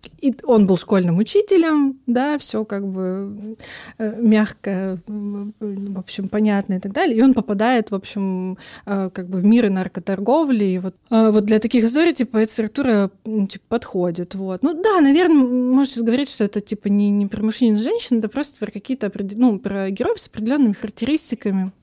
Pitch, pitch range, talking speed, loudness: 215 Hz, 200-245 Hz, 180 wpm, -19 LUFS